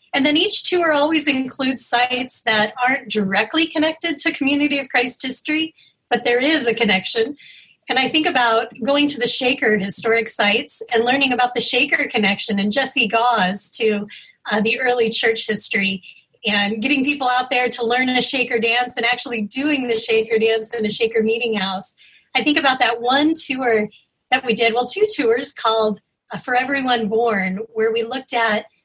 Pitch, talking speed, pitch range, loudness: 240 Hz, 185 wpm, 225-265 Hz, -17 LUFS